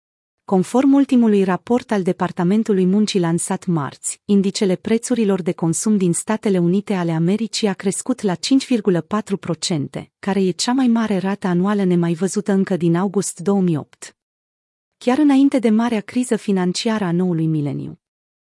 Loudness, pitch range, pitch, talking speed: -18 LUFS, 175-220 Hz, 195 Hz, 140 wpm